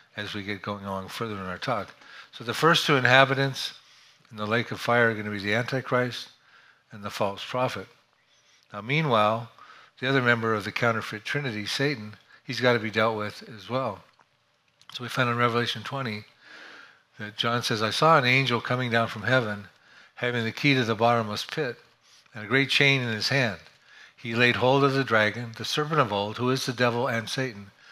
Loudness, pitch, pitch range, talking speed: -25 LUFS, 120 Hz, 110-135 Hz, 200 wpm